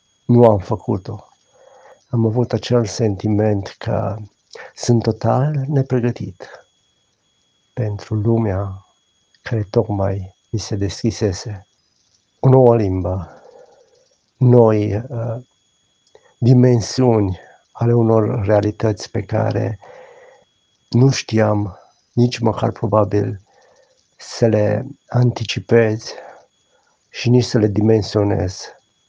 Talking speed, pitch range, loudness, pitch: 85 wpm, 105-120 Hz, -17 LUFS, 110 Hz